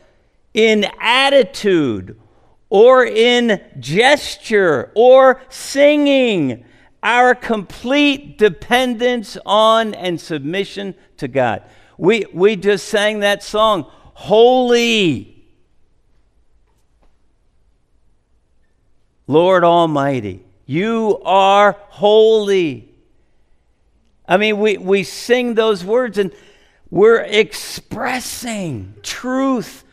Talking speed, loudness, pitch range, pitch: 75 wpm, -14 LUFS, 180-245 Hz, 210 Hz